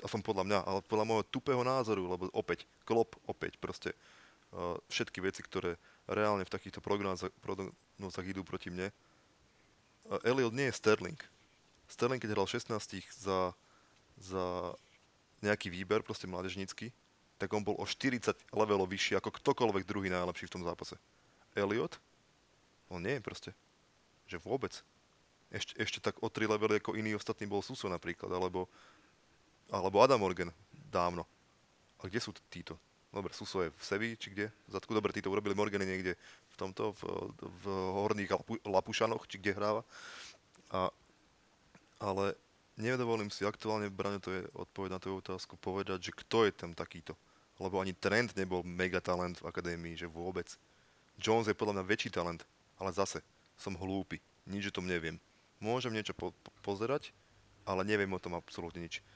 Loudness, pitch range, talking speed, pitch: -37 LUFS, 95-110 Hz, 160 wpm, 100 Hz